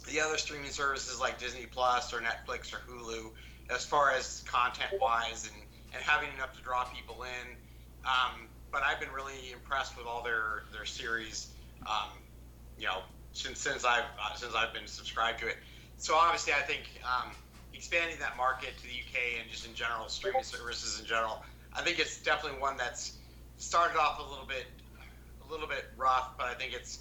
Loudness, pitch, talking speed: -34 LUFS, 115 Hz, 190 wpm